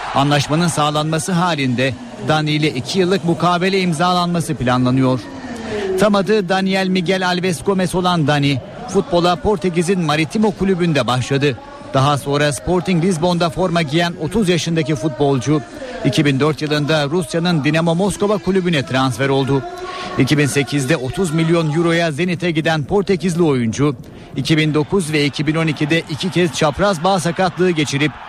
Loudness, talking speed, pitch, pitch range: -17 LUFS, 120 wpm, 165 Hz, 150-185 Hz